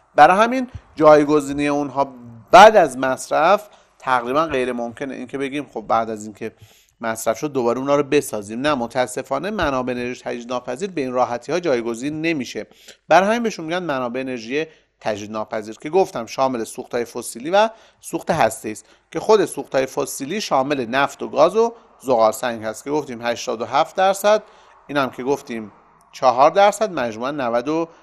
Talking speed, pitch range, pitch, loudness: 160 wpm, 120-155 Hz, 135 Hz, -19 LUFS